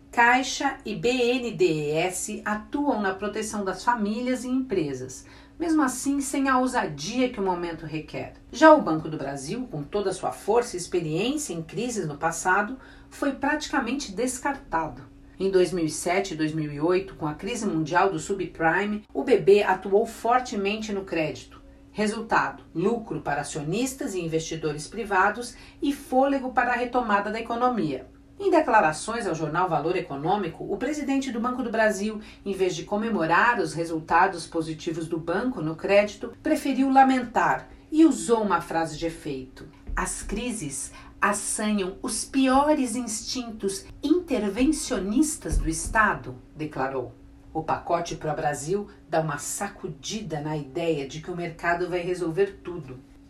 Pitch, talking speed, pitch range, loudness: 195 Hz, 140 wpm, 160-245 Hz, -25 LUFS